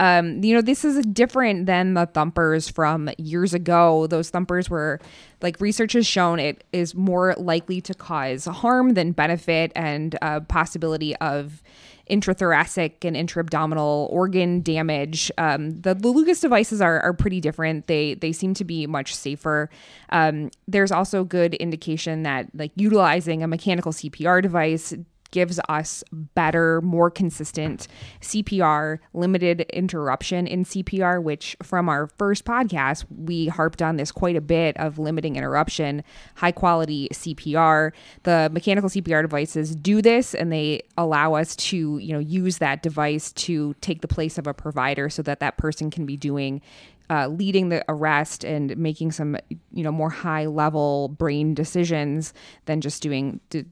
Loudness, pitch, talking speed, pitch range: -22 LUFS, 160 Hz, 160 wpm, 155-180 Hz